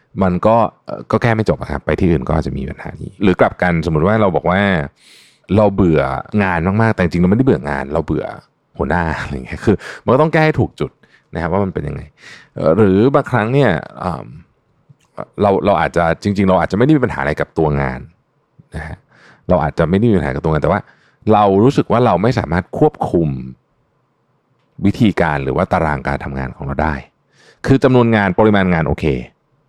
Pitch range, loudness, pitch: 75-110 Hz, -15 LUFS, 95 Hz